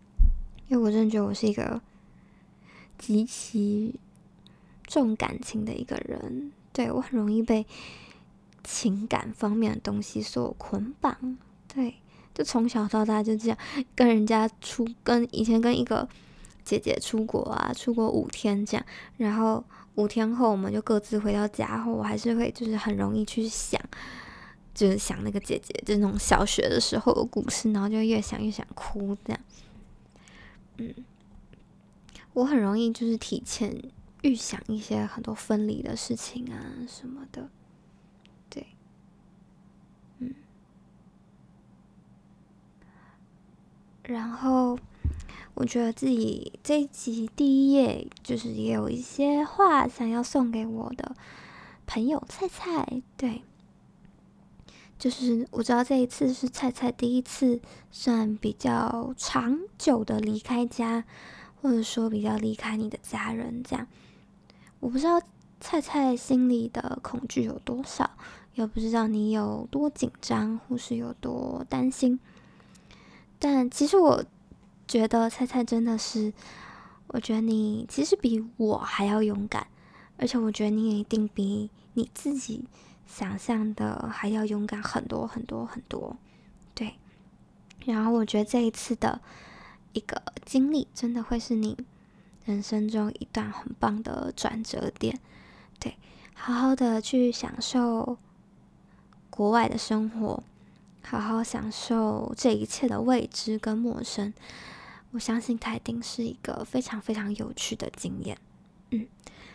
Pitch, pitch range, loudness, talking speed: 230 Hz, 215-250 Hz, -28 LUFS, 200 characters per minute